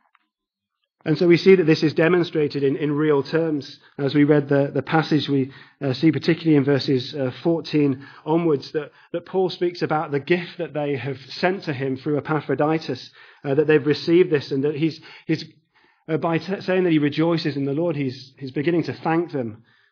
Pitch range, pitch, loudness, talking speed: 140-165 Hz, 150 Hz, -21 LUFS, 200 wpm